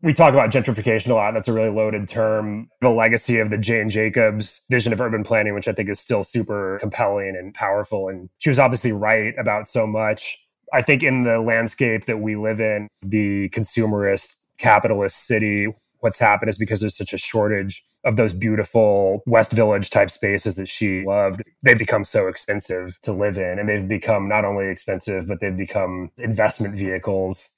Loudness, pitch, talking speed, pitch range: -20 LUFS, 105 Hz, 190 wpm, 100-110 Hz